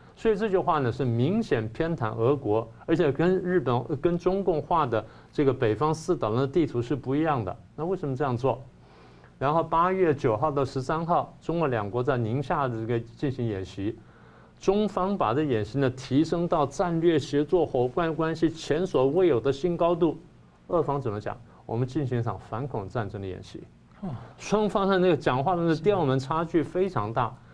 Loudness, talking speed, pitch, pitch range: -26 LUFS, 275 characters per minute, 145 Hz, 120-170 Hz